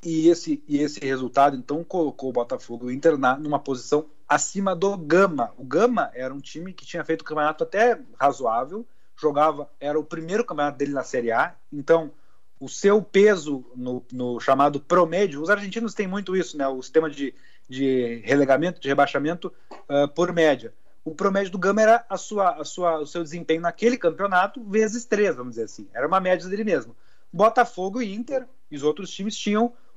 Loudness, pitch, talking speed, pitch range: -23 LUFS, 165 Hz, 190 wpm, 140-200 Hz